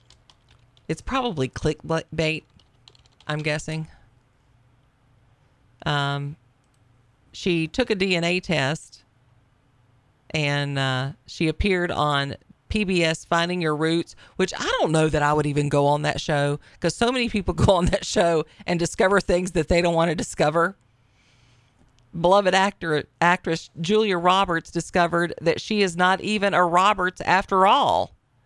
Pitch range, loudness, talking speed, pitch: 130-180 Hz, -22 LUFS, 135 wpm, 155 Hz